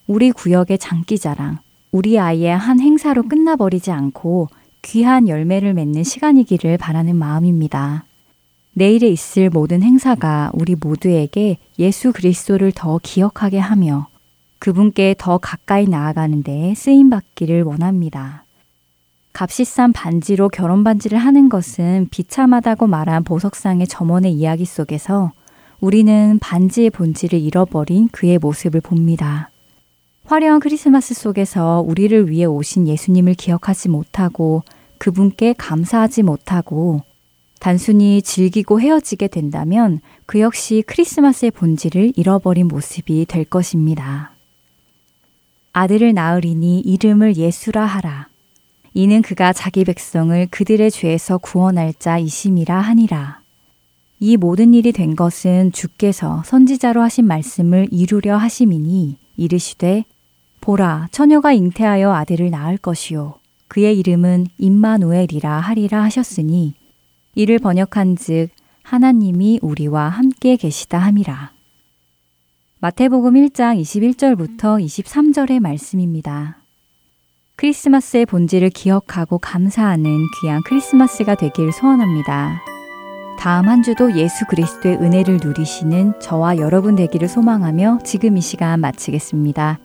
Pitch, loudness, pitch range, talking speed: 180 Hz, -15 LUFS, 160-215 Hz, 295 characters per minute